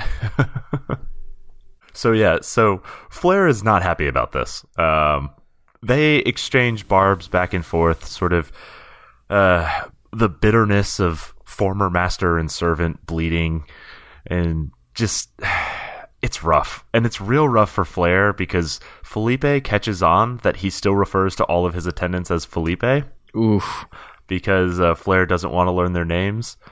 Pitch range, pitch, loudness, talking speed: 85-110 Hz, 90 Hz, -19 LUFS, 140 wpm